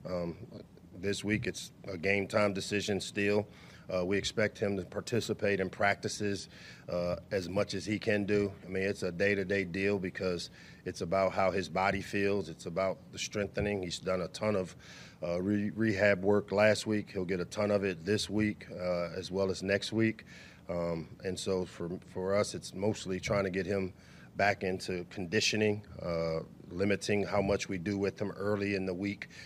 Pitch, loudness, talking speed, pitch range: 100 Hz, -33 LUFS, 195 wpm, 95-105 Hz